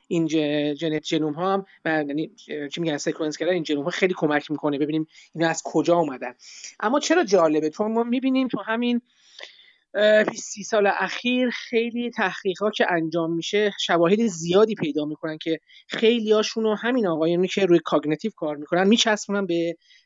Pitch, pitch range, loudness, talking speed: 180 Hz, 160-220 Hz, -23 LUFS, 160 wpm